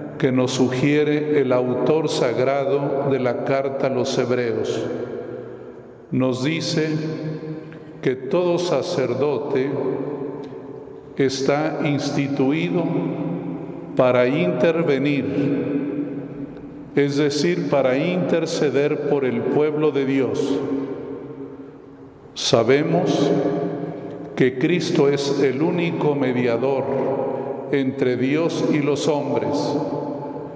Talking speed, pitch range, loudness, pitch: 80 wpm, 135-150 Hz, -21 LUFS, 140 Hz